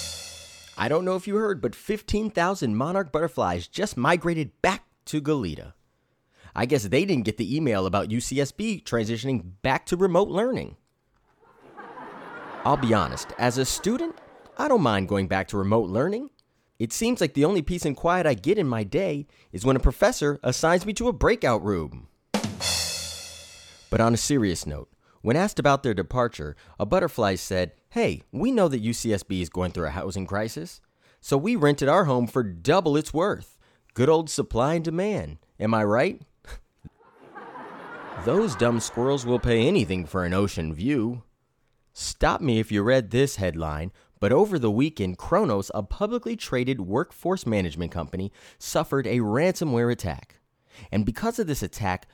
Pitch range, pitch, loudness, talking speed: 100-165 Hz, 120 Hz, -25 LUFS, 165 wpm